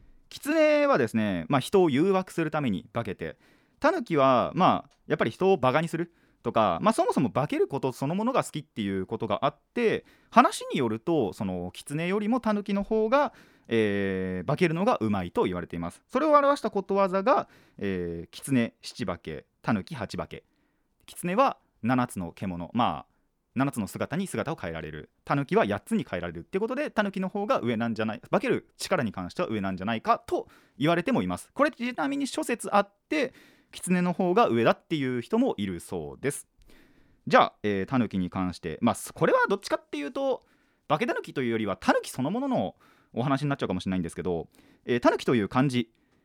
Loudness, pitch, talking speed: -27 LUFS, 145 Hz, 390 characters per minute